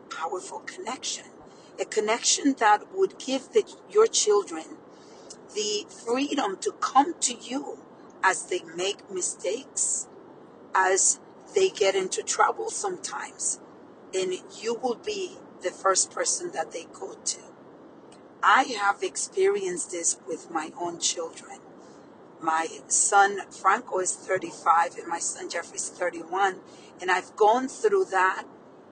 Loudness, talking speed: -26 LUFS, 125 wpm